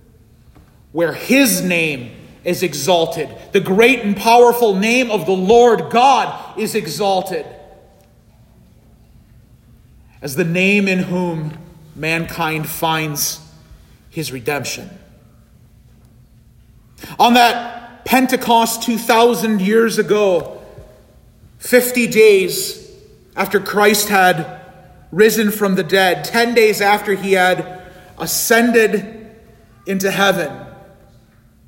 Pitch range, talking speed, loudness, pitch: 160-225 Hz, 90 wpm, -15 LUFS, 190 Hz